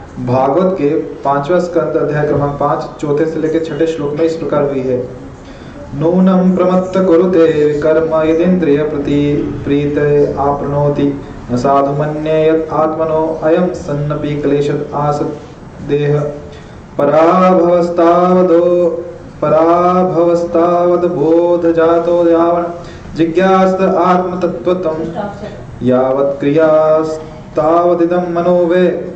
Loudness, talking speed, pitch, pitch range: -12 LUFS, 35 wpm, 160 Hz, 145-175 Hz